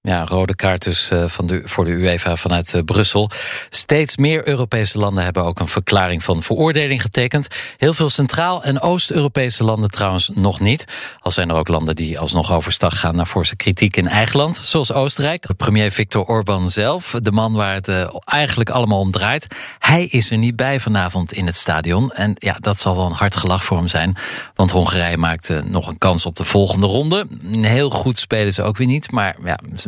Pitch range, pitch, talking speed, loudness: 90-125 Hz, 100 Hz, 205 wpm, -16 LUFS